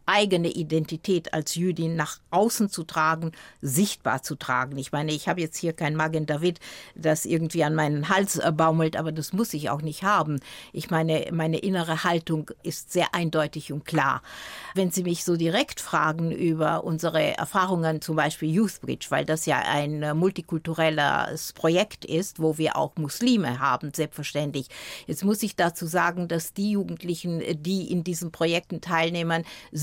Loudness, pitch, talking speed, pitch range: -26 LUFS, 165 Hz, 165 wpm, 155-175 Hz